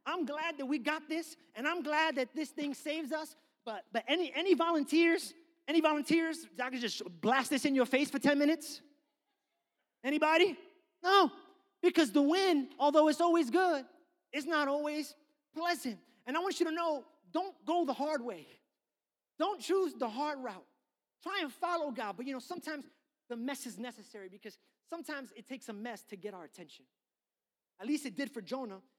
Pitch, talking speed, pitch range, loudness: 300 Hz, 185 wpm, 260-330 Hz, -33 LUFS